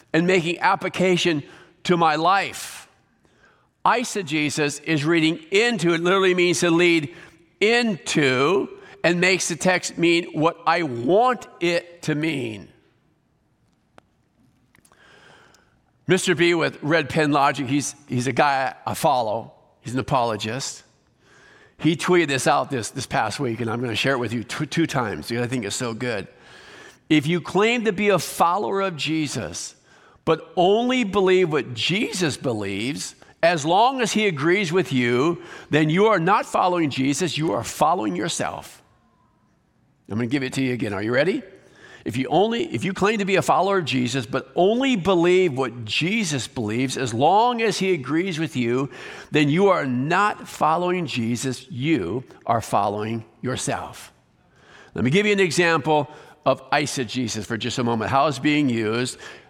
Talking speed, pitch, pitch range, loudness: 165 wpm, 160 Hz, 130-185 Hz, -21 LUFS